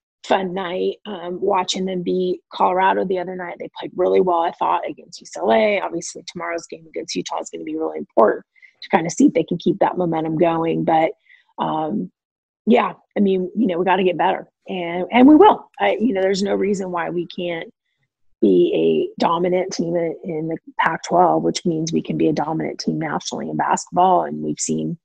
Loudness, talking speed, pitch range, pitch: -19 LUFS, 205 wpm, 165-190 Hz, 180 Hz